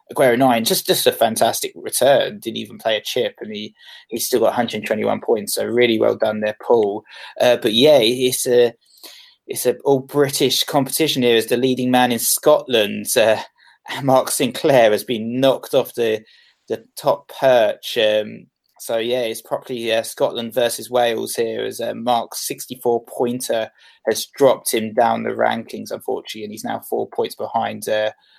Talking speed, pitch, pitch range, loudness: 175 wpm, 120 Hz, 115-140 Hz, -18 LUFS